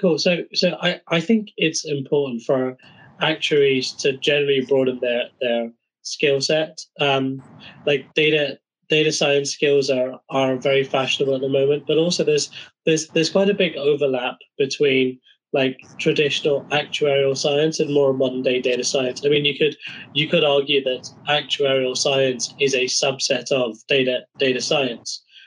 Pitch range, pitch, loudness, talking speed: 130-155 Hz, 140 Hz, -20 LUFS, 155 wpm